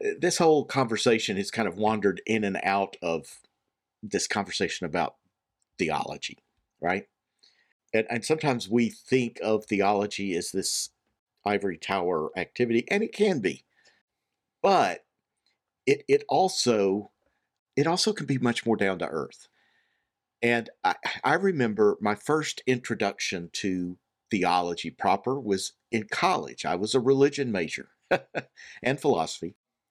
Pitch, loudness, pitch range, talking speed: 115 Hz, -27 LUFS, 100-140 Hz, 130 wpm